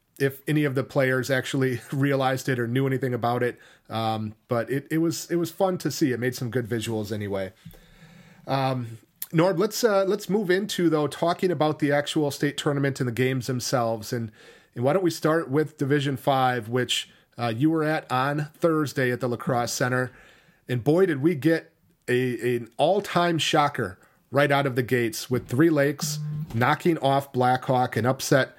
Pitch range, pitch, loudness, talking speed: 125-155 Hz, 140 Hz, -25 LUFS, 190 wpm